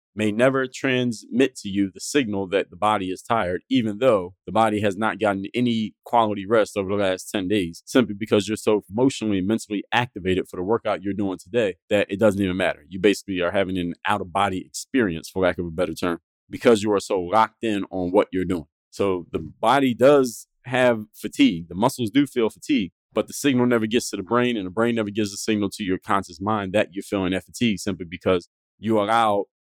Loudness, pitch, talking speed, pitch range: -23 LUFS, 105 Hz, 220 wpm, 95-115 Hz